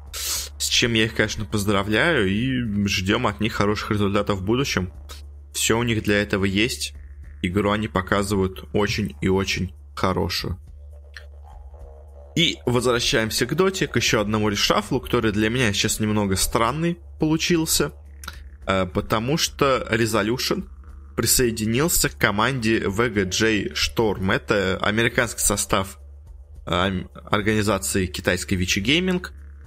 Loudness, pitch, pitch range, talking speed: -22 LUFS, 105 Hz, 75-110 Hz, 115 wpm